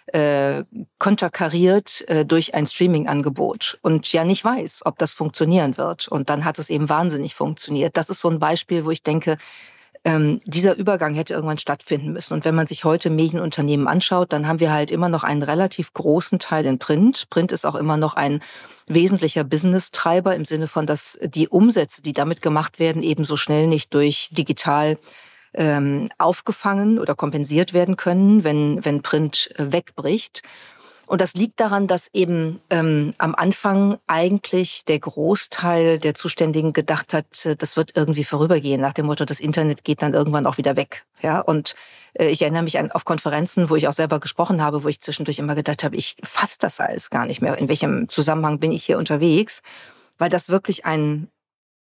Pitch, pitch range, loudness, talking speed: 160 Hz, 150-175 Hz, -20 LUFS, 180 wpm